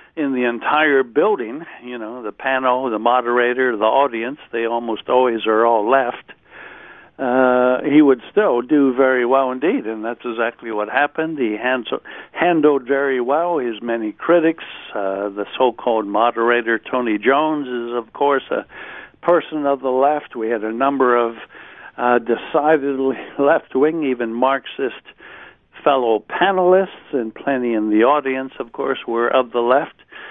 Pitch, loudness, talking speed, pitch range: 125 Hz, -18 LUFS, 155 wpm, 115-140 Hz